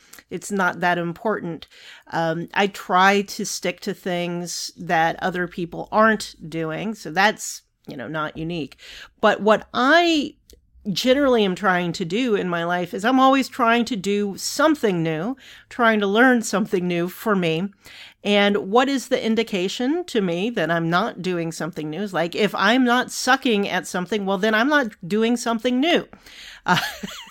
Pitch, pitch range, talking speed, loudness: 205 Hz, 175-230 Hz, 170 wpm, -21 LUFS